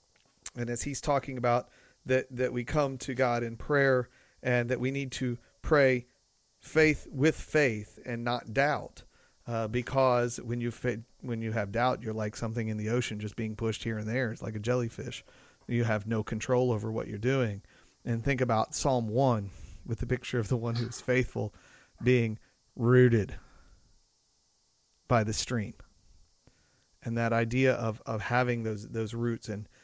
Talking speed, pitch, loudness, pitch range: 175 wpm, 120 Hz, -30 LUFS, 110-125 Hz